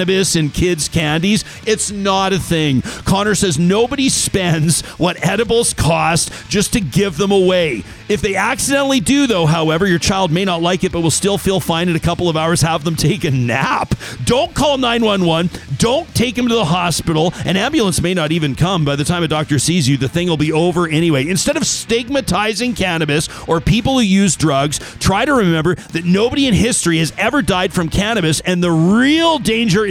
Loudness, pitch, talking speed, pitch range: -15 LUFS, 180 Hz, 205 wpm, 160-205 Hz